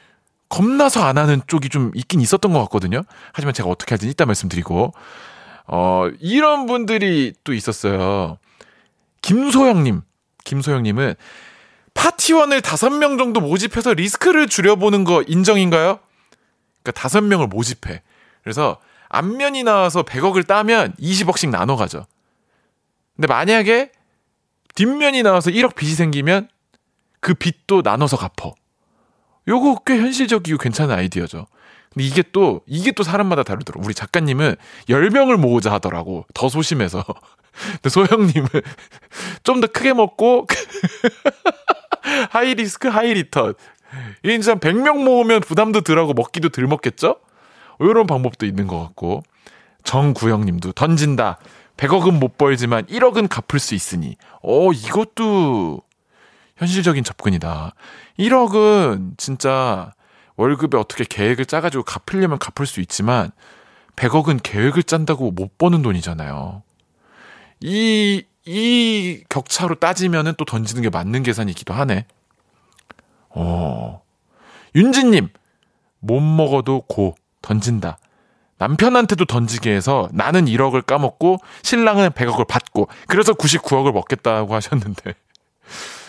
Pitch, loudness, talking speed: 160 Hz, -17 LUFS, 270 characters per minute